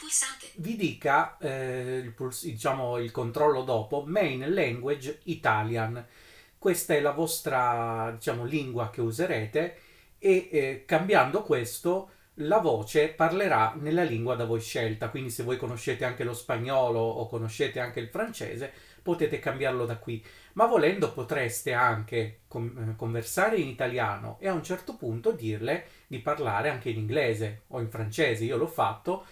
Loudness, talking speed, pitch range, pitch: -29 LUFS, 145 wpm, 115-155 Hz, 125 Hz